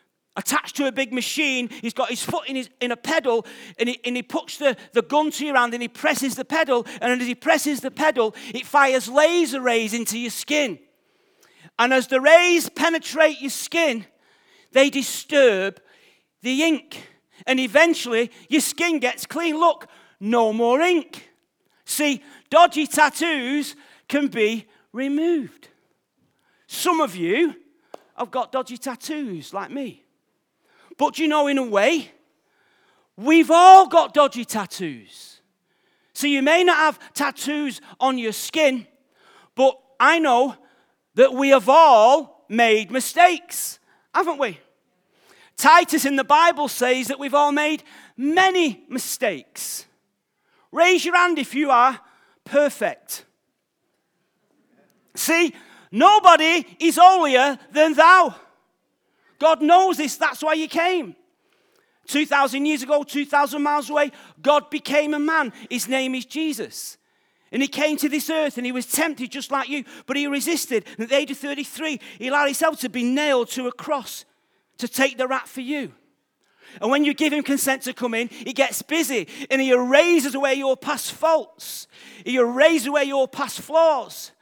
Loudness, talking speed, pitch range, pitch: -20 LUFS, 155 wpm, 255-315 Hz, 285 Hz